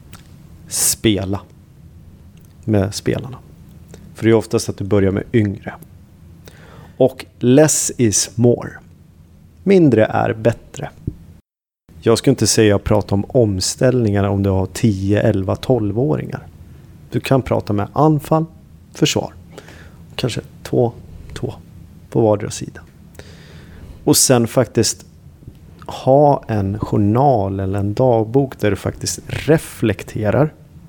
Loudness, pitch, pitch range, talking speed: -17 LUFS, 105 Hz, 95-125 Hz, 115 wpm